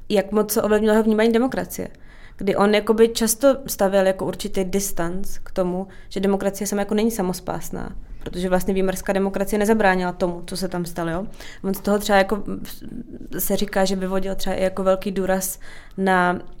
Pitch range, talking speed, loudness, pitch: 185-210 Hz, 170 wpm, -21 LUFS, 195 Hz